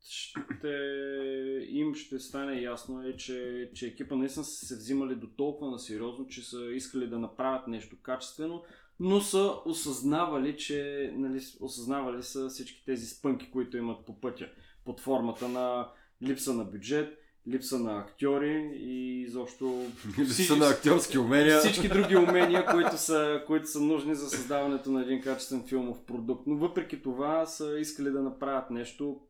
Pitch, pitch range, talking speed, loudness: 135 Hz, 125-150 Hz, 155 wpm, -31 LUFS